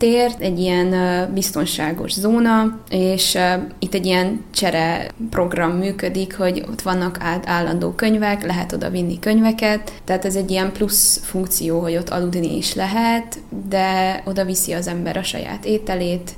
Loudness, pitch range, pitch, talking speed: -19 LUFS, 180-205 Hz, 185 Hz, 150 wpm